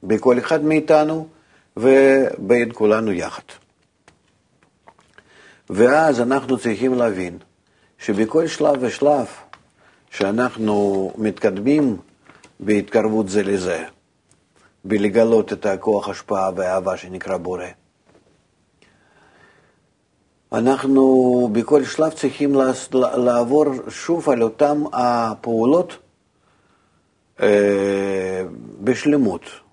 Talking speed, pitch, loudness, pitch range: 70 wpm, 120 Hz, -18 LUFS, 105-135 Hz